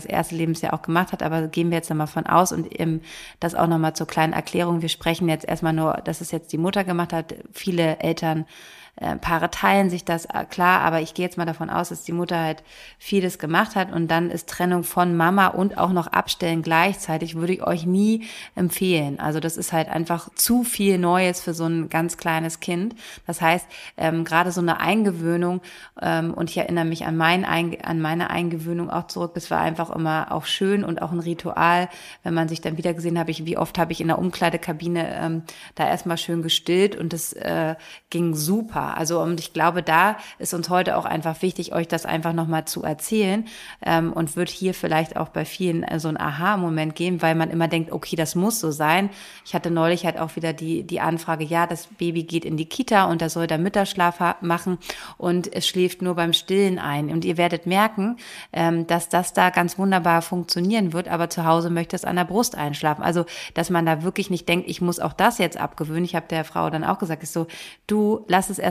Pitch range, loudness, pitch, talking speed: 165-180 Hz, -23 LUFS, 170 Hz, 220 wpm